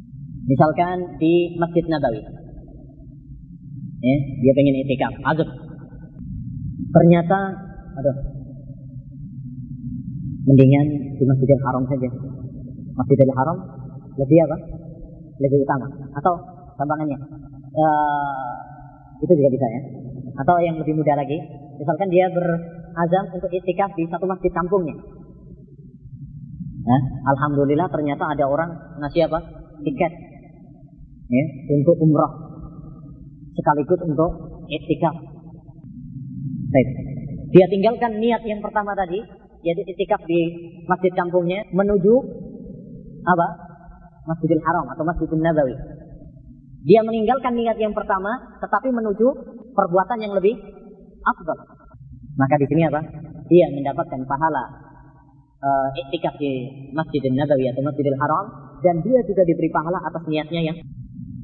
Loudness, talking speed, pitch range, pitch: -20 LUFS, 105 wpm, 140-175 Hz, 155 Hz